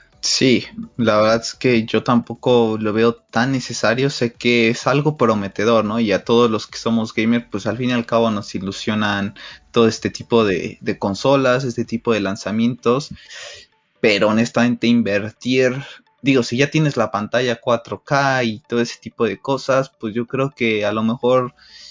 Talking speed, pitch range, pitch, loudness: 180 wpm, 110-125 Hz, 115 Hz, -18 LUFS